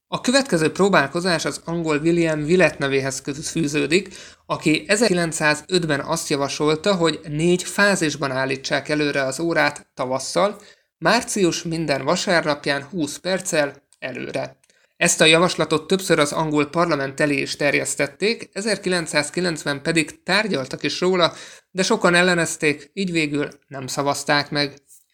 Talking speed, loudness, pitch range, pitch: 120 wpm, -20 LUFS, 145-175 Hz, 160 Hz